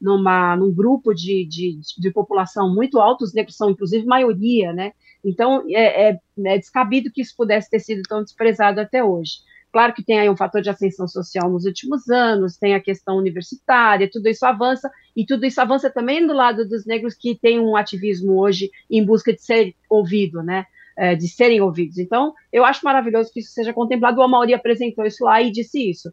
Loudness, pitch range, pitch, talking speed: -18 LUFS, 195-240 Hz, 220 Hz, 200 wpm